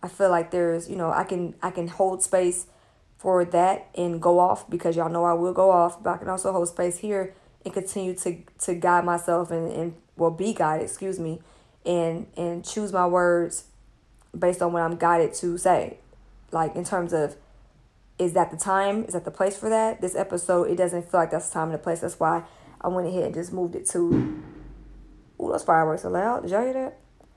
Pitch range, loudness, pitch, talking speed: 170-185 Hz, -25 LUFS, 175 Hz, 220 wpm